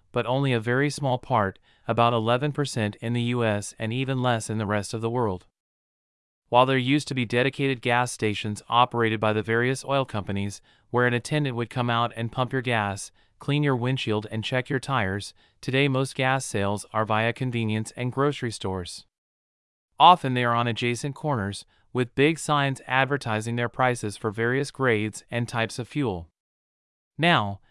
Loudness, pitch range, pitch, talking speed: -25 LUFS, 110-130 Hz, 120 Hz, 175 wpm